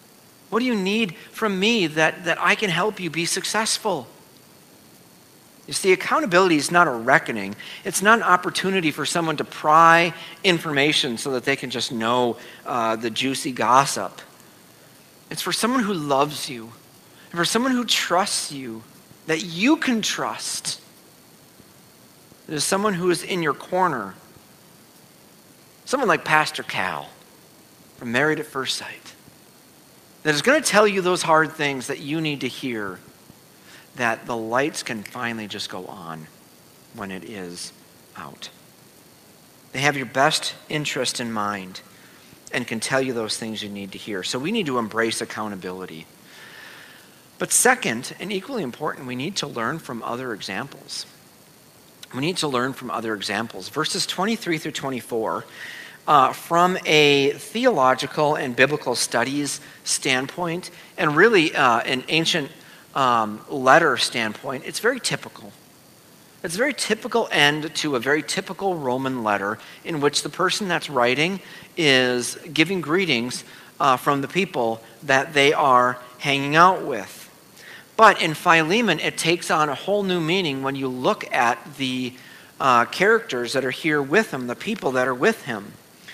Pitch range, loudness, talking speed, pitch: 125-175 Hz, -21 LUFS, 155 wpm, 150 Hz